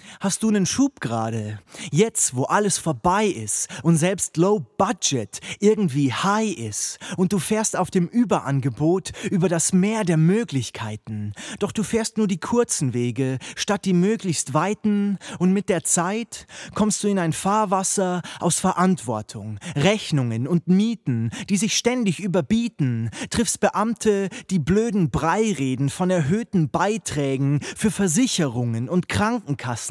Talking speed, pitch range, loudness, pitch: 140 wpm, 145-205 Hz, -22 LUFS, 185 Hz